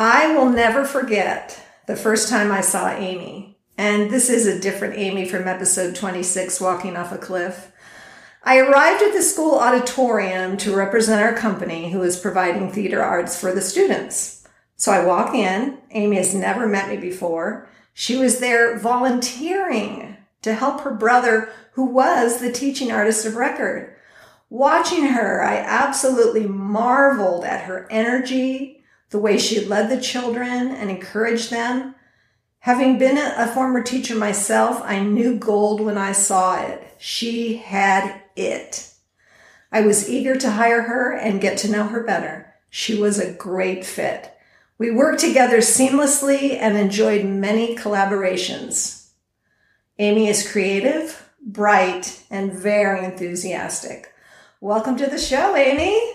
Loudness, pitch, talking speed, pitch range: -19 LUFS, 220 Hz, 145 wpm, 195-255 Hz